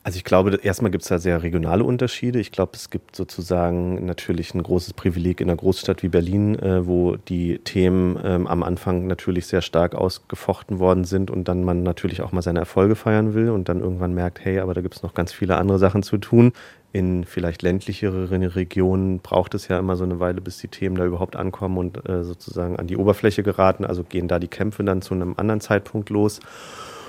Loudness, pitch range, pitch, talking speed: -22 LUFS, 90-100 Hz, 95 Hz, 210 wpm